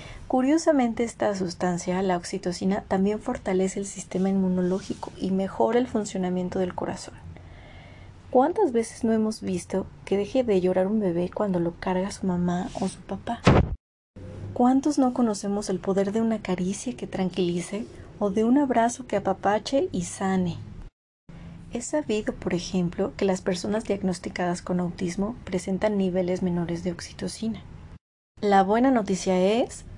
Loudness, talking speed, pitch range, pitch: -26 LUFS, 145 wpm, 180-220 Hz, 195 Hz